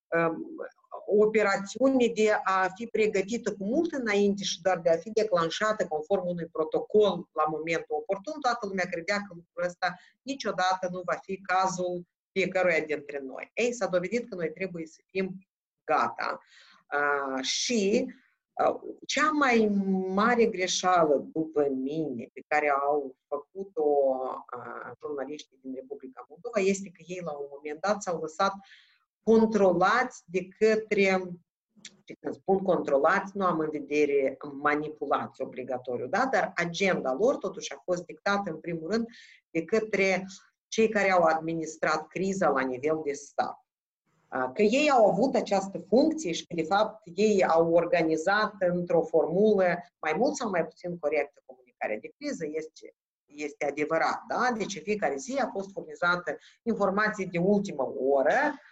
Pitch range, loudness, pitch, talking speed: 155-210 Hz, -28 LUFS, 185 Hz, 145 wpm